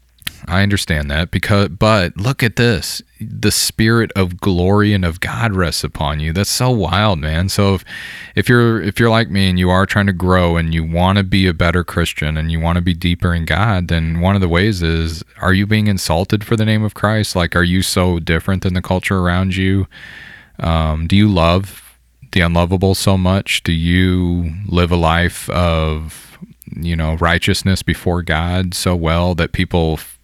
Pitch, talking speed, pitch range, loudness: 90 Hz, 200 wpm, 85-100 Hz, -15 LUFS